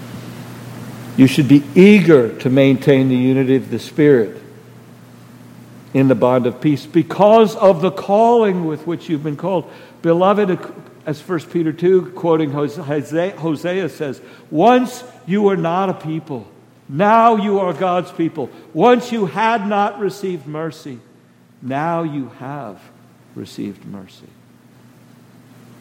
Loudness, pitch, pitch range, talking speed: -16 LUFS, 160 Hz, 135-190 Hz, 130 wpm